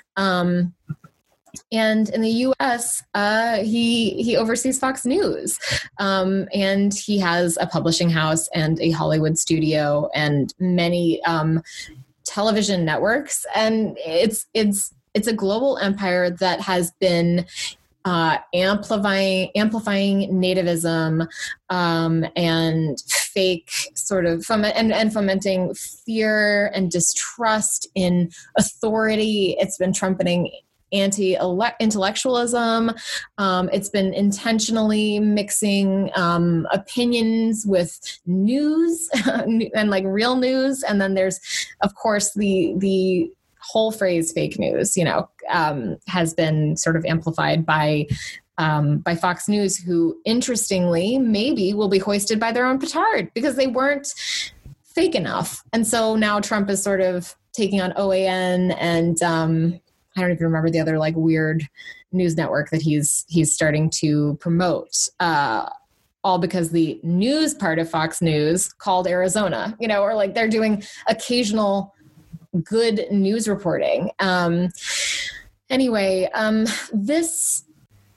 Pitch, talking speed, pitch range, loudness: 190 Hz, 125 wpm, 170-220 Hz, -21 LUFS